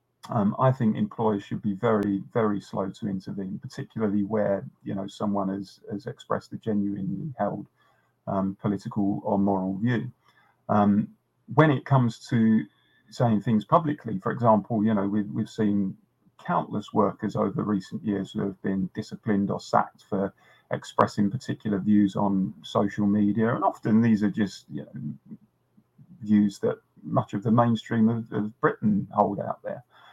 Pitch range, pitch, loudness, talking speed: 100-115 Hz, 105 Hz, -26 LUFS, 155 wpm